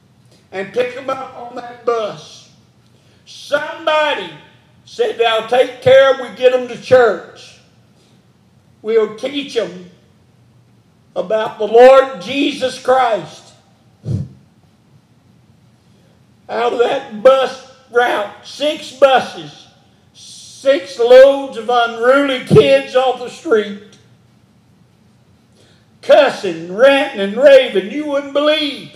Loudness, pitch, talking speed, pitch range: -14 LUFS, 255 Hz, 100 wpm, 215-275 Hz